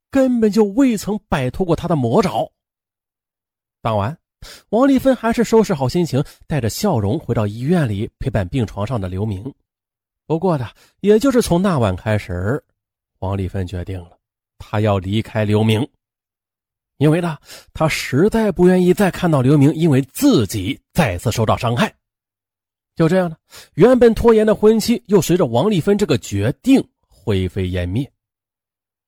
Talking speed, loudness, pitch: 235 characters per minute, -17 LUFS, 120 Hz